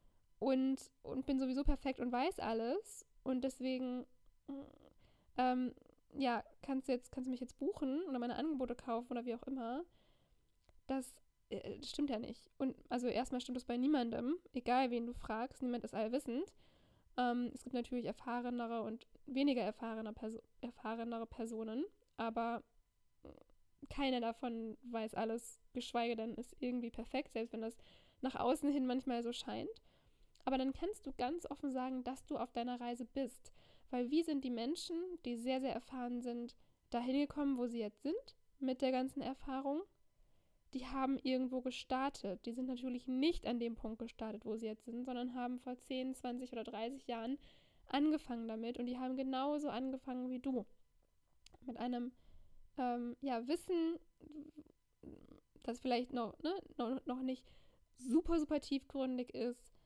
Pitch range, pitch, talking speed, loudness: 240-270 Hz, 255 Hz, 160 wpm, -41 LUFS